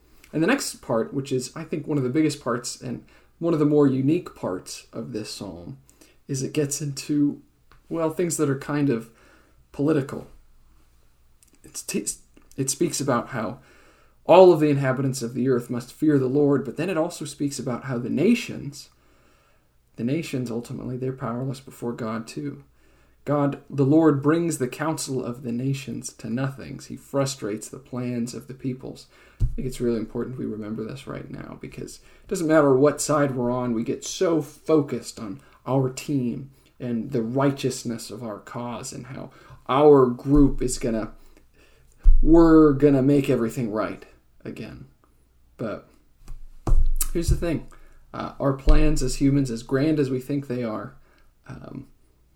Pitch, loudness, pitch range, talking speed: 130 Hz, -24 LUFS, 120-145 Hz, 165 wpm